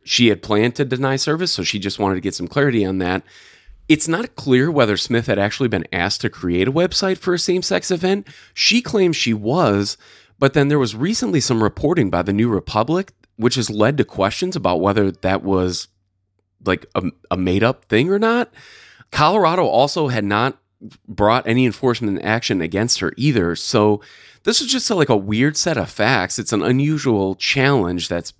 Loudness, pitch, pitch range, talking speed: -18 LUFS, 115 Hz, 100-145 Hz, 195 wpm